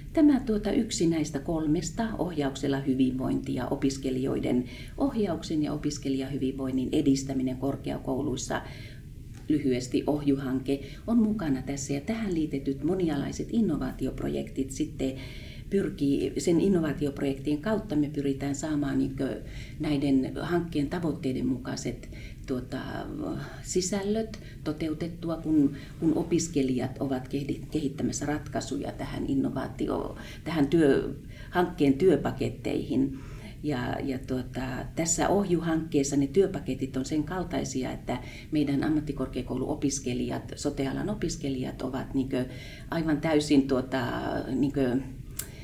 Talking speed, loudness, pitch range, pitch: 95 wpm, -29 LUFS, 130-155 Hz, 140 Hz